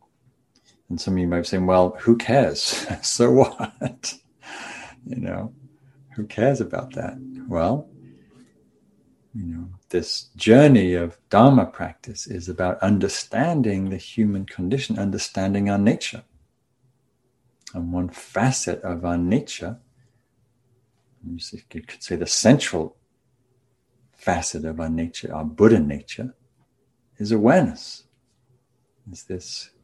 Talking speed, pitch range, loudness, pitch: 110 wpm, 90-125 Hz, -21 LUFS, 115 Hz